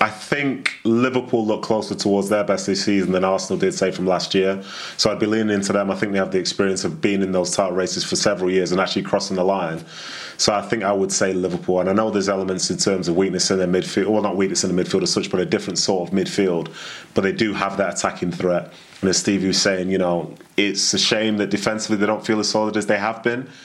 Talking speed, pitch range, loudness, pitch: 265 wpm, 95-110 Hz, -20 LUFS, 100 Hz